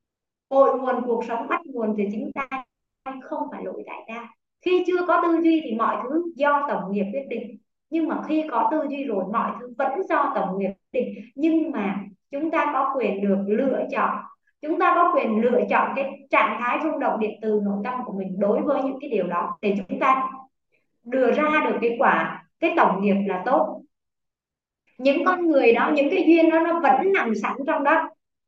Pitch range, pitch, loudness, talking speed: 220-305 Hz, 265 Hz, -22 LUFS, 215 wpm